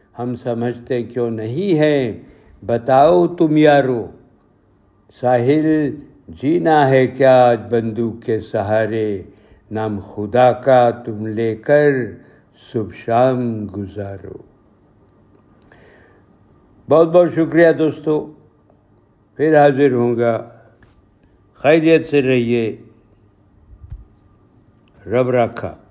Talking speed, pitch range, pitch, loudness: 90 wpm, 105-135 Hz, 120 Hz, -16 LUFS